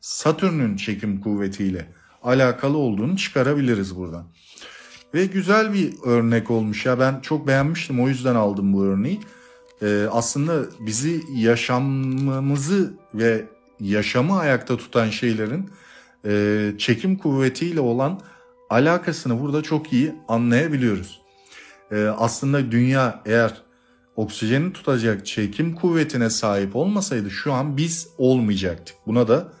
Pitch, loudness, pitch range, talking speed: 125 Hz, -21 LUFS, 105-150 Hz, 110 wpm